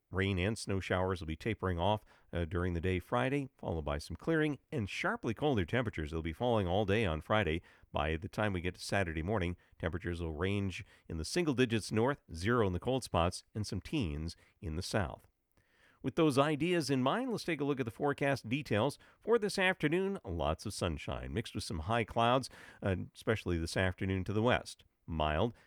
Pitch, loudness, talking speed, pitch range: 105 Hz, -35 LUFS, 205 wpm, 90-130 Hz